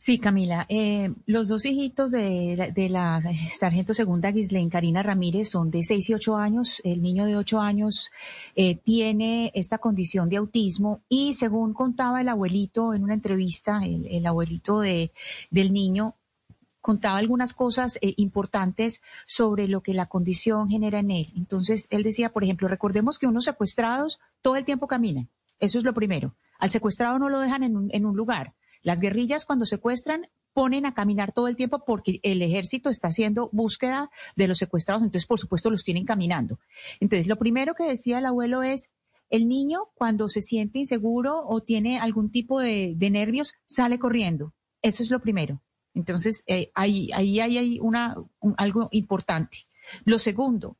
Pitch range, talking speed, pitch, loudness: 195-240 Hz, 175 wpm, 215 Hz, -25 LUFS